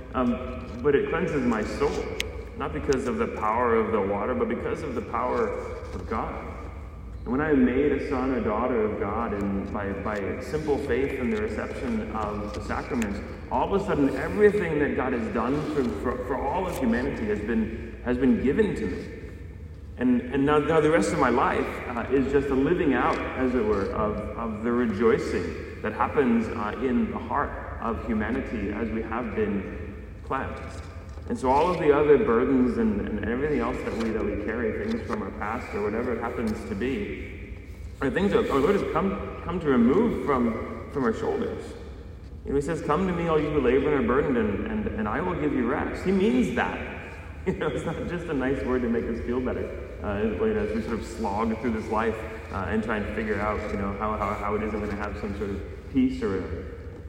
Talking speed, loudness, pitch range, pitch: 220 wpm, -26 LUFS, 100-140 Hz, 110 Hz